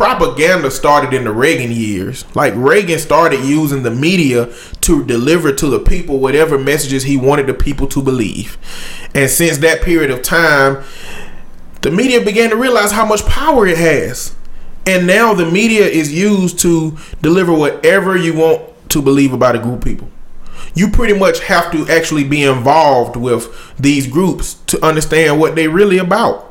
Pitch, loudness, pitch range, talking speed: 155 Hz, -12 LUFS, 135-180 Hz, 170 wpm